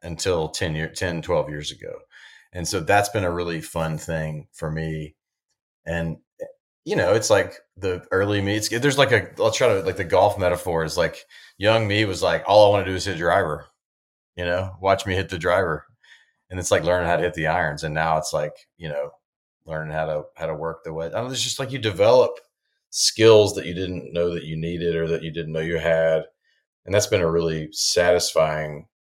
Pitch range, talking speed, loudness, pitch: 80-100 Hz, 225 wpm, -22 LUFS, 85 Hz